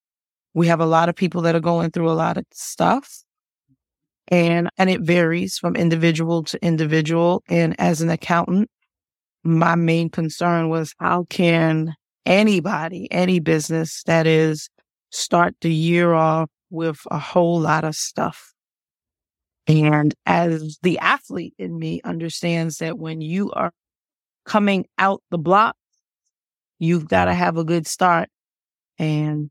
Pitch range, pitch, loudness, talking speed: 160-175 Hz, 165 Hz, -20 LUFS, 140 wpm